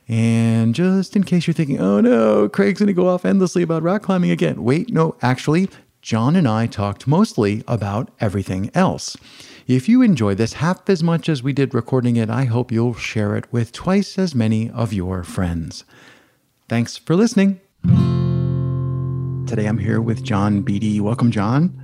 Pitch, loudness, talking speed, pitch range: 130 Hz, -18 LUFS, 175 wpm, 110-175 Hz